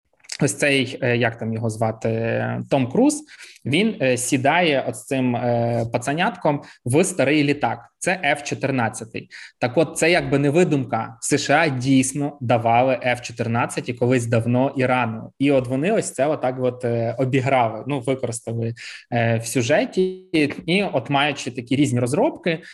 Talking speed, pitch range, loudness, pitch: 140 wpm, 120-145 Hz, -21 LUFS, 130 Hz